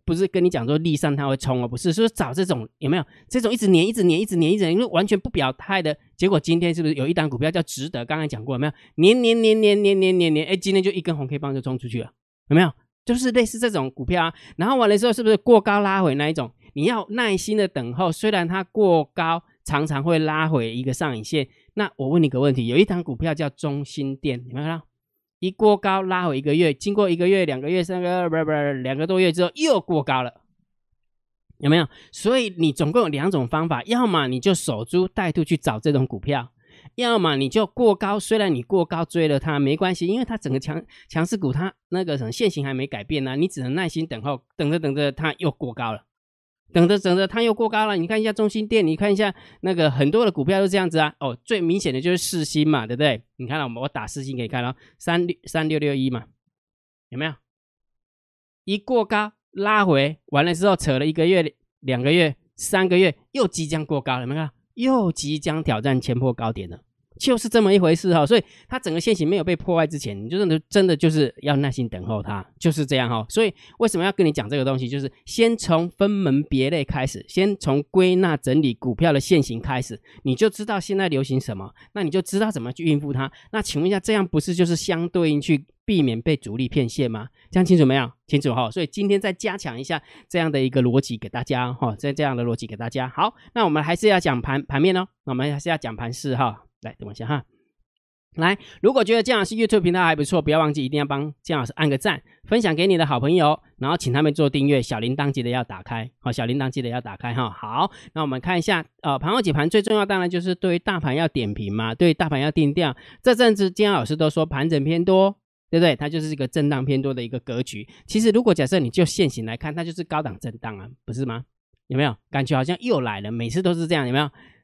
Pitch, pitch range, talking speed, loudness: 155 Hz, 135-185 Hz, 360 characters per minute, -22 LUFS